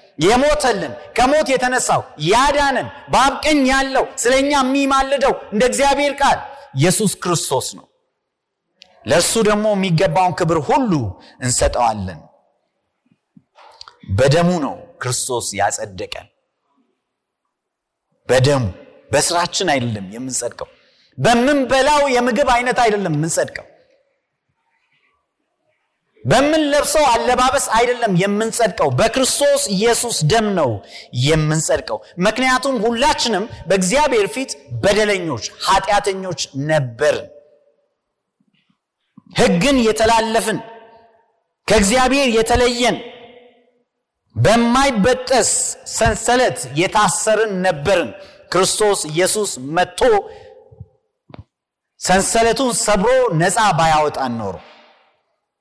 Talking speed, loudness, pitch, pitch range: 70 wpm, -16 LUFS, 225 Hz, 170-260 Hz